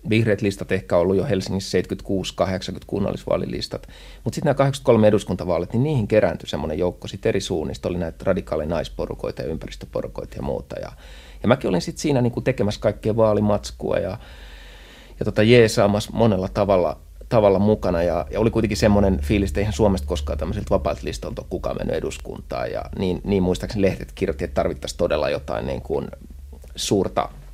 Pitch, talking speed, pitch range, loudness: 100 Hz, 170 wpm, 85-105 Hz, -22 LUFS